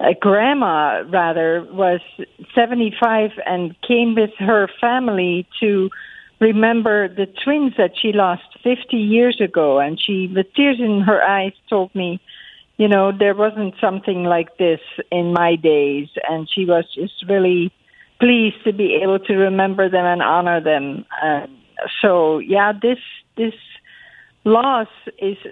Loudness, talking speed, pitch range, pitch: -17 LUFS, 145 wpm, 180-220 Hz, 195 Hz